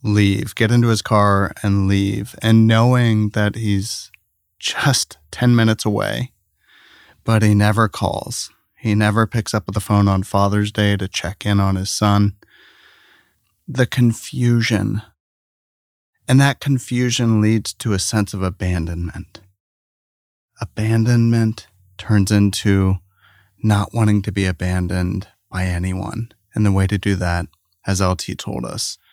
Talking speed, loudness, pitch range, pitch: 135 wpm, -18 LUFS, 95-110 Hz, 105 Hz